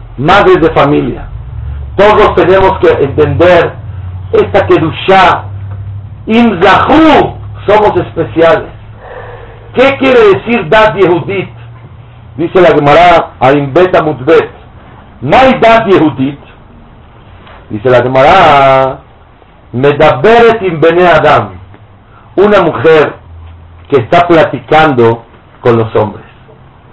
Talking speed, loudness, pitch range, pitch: 85 wpm, -7 LUFS, 115-180 Hz, 145 Hz